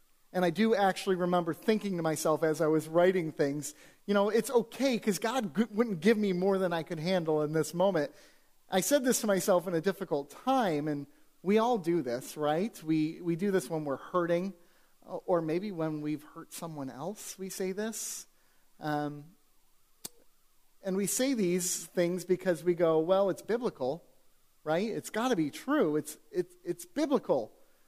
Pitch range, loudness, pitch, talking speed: 160-205 Hz, -31 LUFS, 180 Hz, 180 wpm